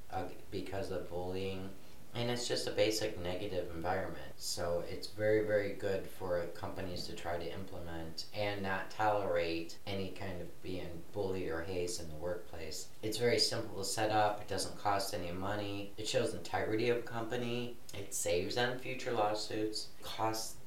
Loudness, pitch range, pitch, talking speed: -37 LUFS, 85-110 Hz, 95 Hz, 170 wpm